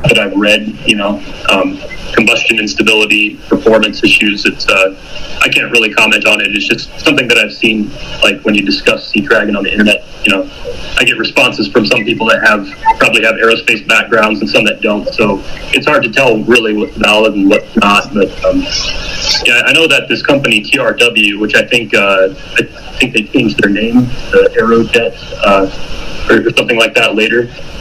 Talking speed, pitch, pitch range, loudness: 195 wpm, 110 Hz, 105-115 Hz, -9 LUFS